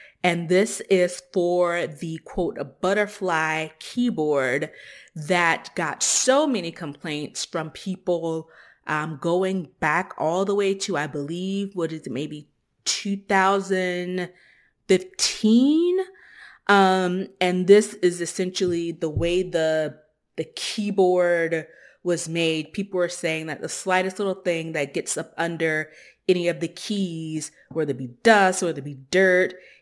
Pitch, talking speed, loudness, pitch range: 175 Hz, 135 wpm, -23 LUFS, 160-190 Hz